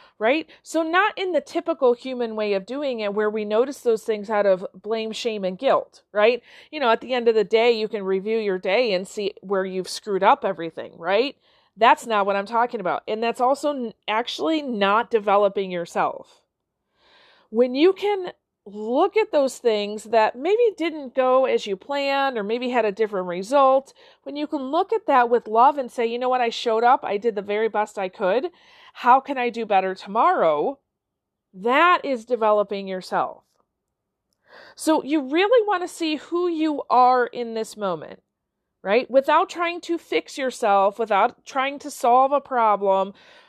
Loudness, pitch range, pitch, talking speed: -22 LUFS, 210-295 Hz, 240 Hz, 185 wpm